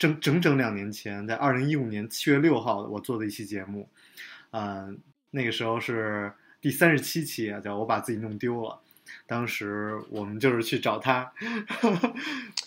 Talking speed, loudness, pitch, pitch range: 250 characters per minute, -28 LUFS, 115 Hz, 105-145 Hz